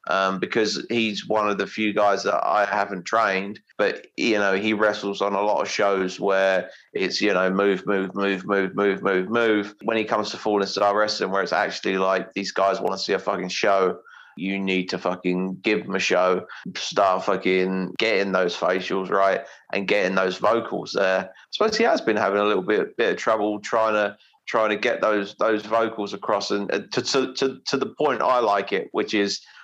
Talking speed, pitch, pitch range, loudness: 210 wpm, 100 Hz, 95-105 Hz, -23 LUFS